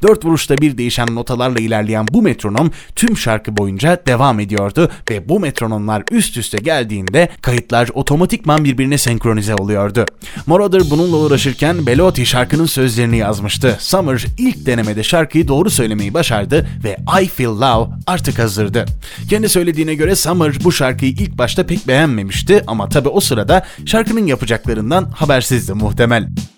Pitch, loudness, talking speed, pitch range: 130 Hz, -14 LUFS, 140 wpm, 115-165 Hz